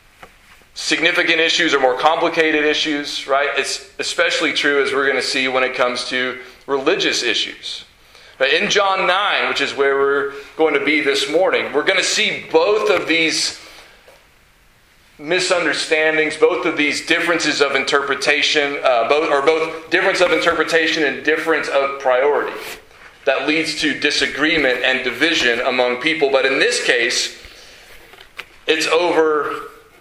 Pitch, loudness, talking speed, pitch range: 155 Hz, -16 LUFS, 145 wpm, 140-170 Hz